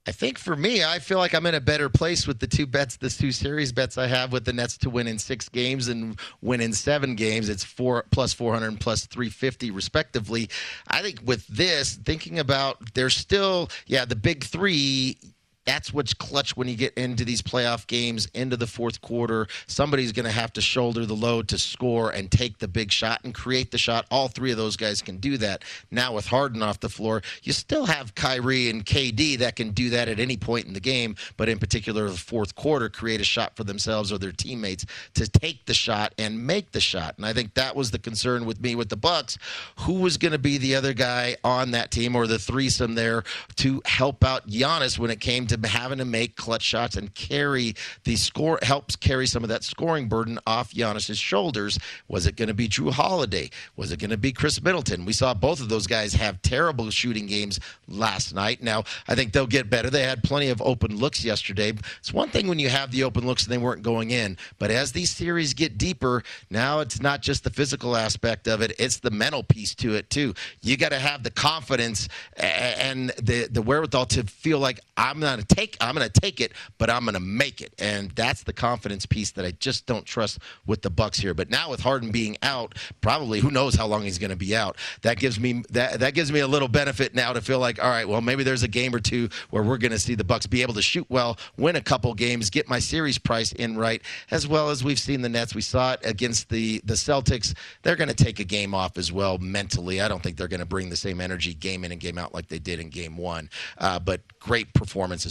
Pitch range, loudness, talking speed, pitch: 110-130 Hz, -25 LUFS, 235 wpm, 120 Hz